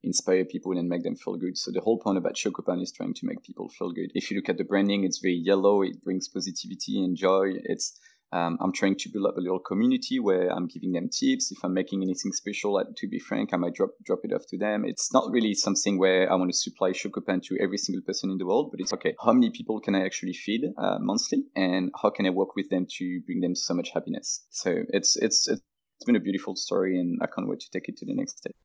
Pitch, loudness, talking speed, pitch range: 95 Hz, -27 LUFS, 265 wpm, 95-115 Hz